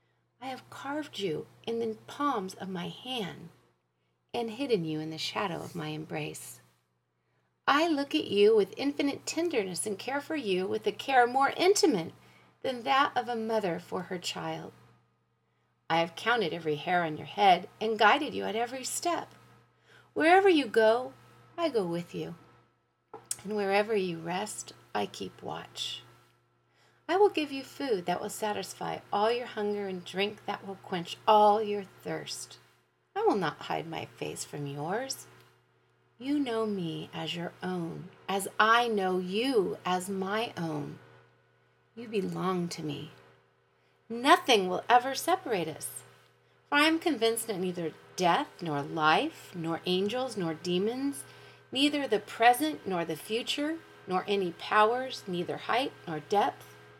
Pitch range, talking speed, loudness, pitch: 165-250 Hz, 155 wpm, -30 LUFS, 200 Hz